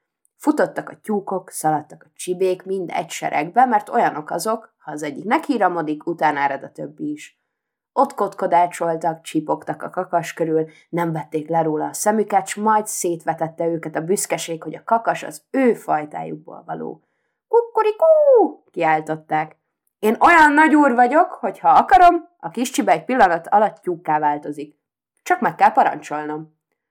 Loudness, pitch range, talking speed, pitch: -19 LUFS, 160-260 Hz, 150 wpm, 185 Hz